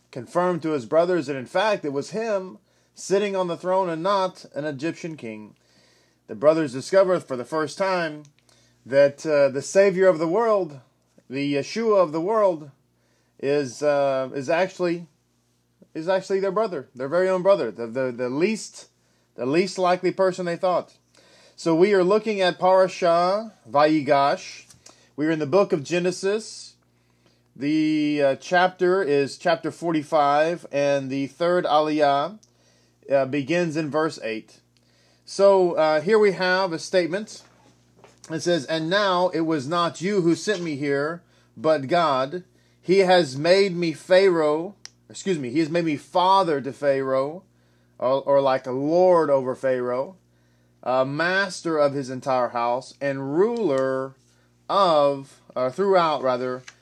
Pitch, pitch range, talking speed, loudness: 155 Hz, 135-185 Hz, 150 wpm, -22 LUFS